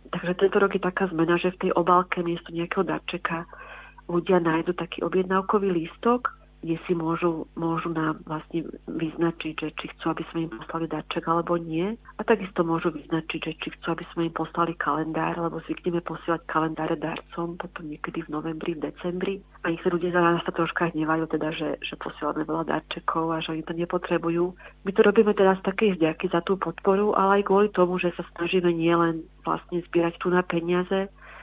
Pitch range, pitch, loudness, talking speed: 165-185 Hz, 170 Hz, -26 LUFS, 190 wpm